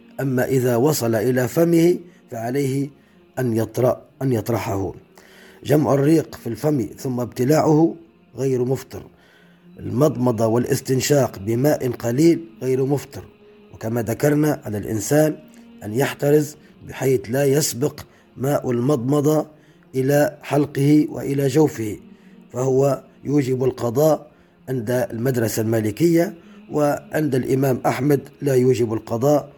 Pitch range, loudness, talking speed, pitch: 120-150 Hz, -20 LUFS, 105 wpm, 135 Hz